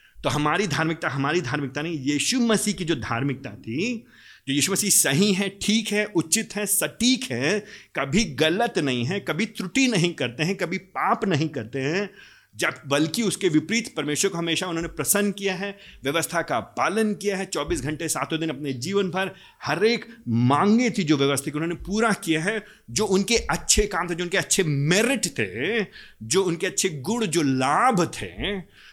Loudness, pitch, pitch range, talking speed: -23 LUFS, 180 Hz, 150-205 Hz, 185 wpm